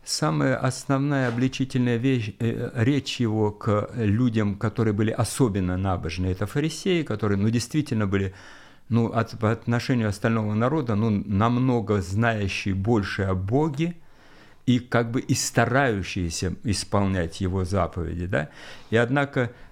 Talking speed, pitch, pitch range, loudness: 130 wpm, 115 Hz, 100-130 Hz, -25 LUFS